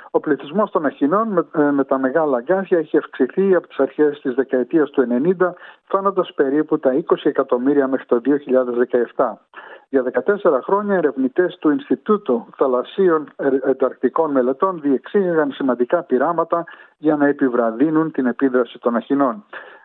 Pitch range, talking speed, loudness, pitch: 130-175 Hz, 135 wpm, -19 LUFS, 145 Hz